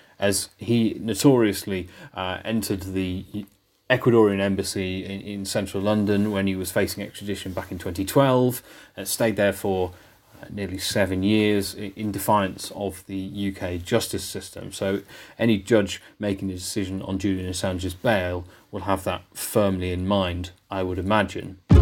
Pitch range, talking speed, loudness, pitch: 95-105 Hz, 150 wpm, -24 LUFS, 100 Hz